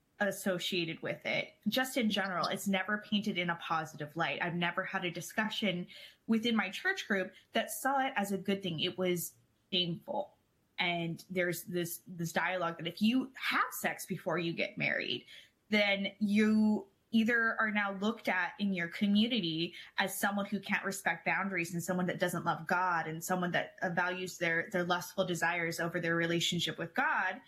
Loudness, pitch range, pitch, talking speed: -33 LUFS, 170-205 Hz, 185 Hz, 175 wpm